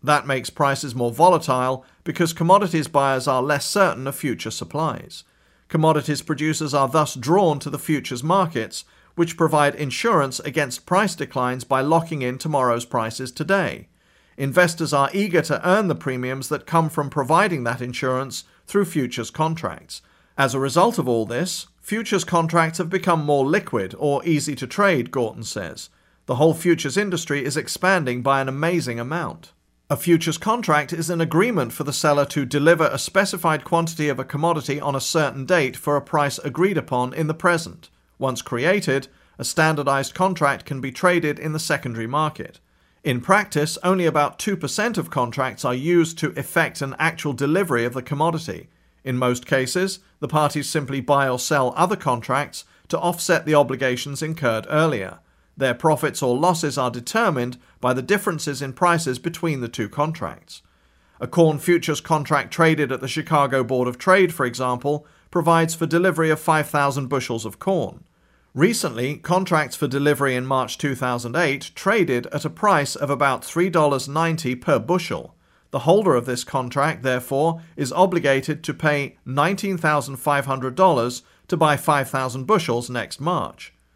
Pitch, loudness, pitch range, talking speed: 150 Hz, -21 LUFS, 130-165 Hz, 160 wpm